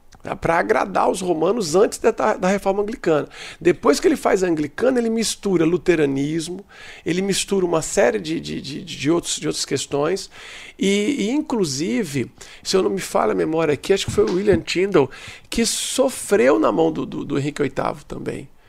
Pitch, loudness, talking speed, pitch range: 195 Hz, -20 LUFS, 185 wpm, 160-225 Hz